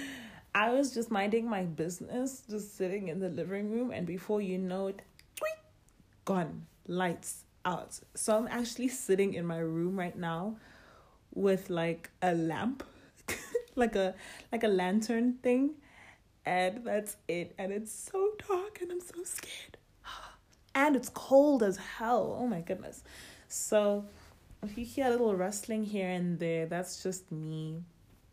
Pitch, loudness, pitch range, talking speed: 205 Hz, -33 LUFS, 180-240 Hz, 150 wpm